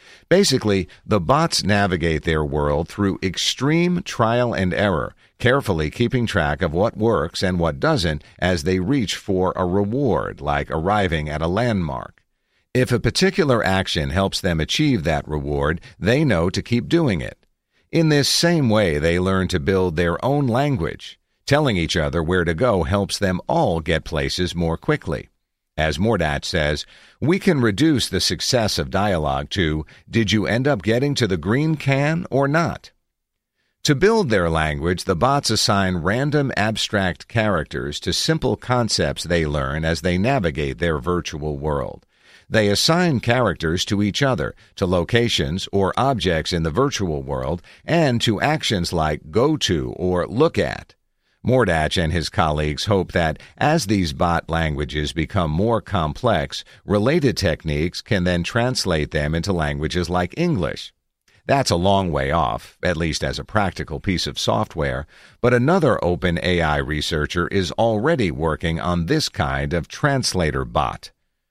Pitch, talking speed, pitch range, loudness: 90 Hz, 155 wpm, 80-115 Hz, -20 LUFS